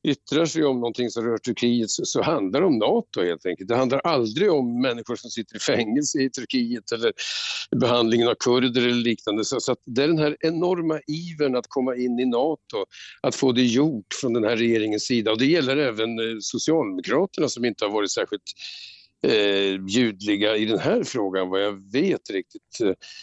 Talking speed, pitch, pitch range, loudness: 190 wpm, 125 Hz, 115-160 Hz, -23 LUFS